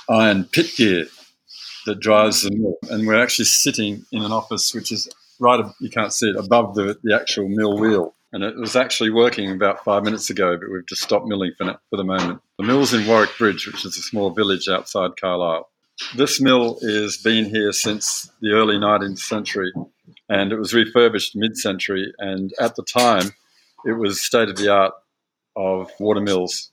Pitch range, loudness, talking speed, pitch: 100-110 Hz, -19 LUFS, 195 wpm, 105 Hz